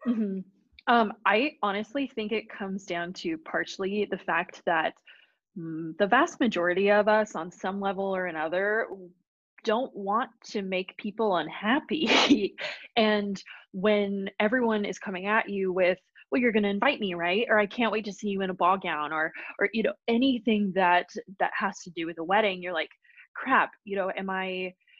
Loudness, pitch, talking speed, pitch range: -27 LUFS, 200 Hz, 180 wpm, 185-220 Hz